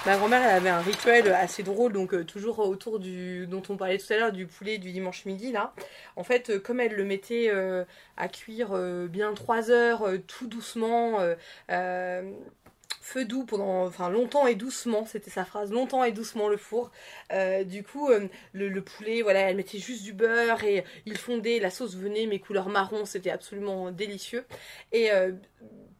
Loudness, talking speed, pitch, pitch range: -28 LUFS, 200 wpm, 205 Hz, 190-230 Hz